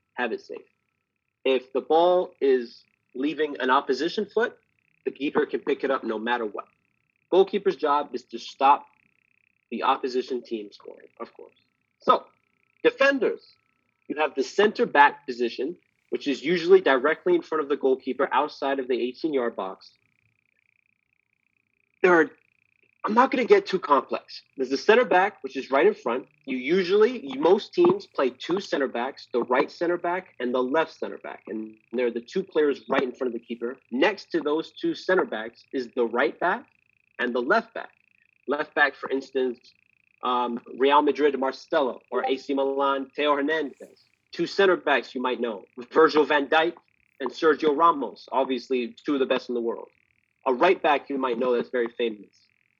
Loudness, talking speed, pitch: -24 LUFS, 180 wpm, 150 Hz